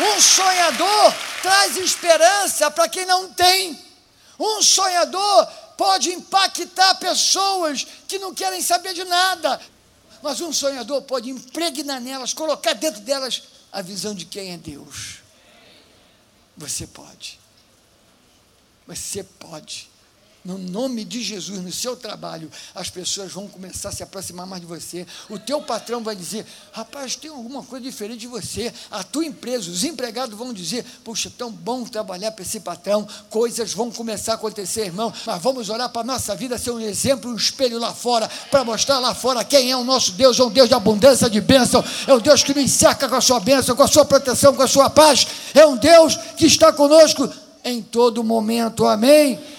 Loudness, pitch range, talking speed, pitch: -17 LUFS, 220-305 Hz, 175 wpm, 255 Hz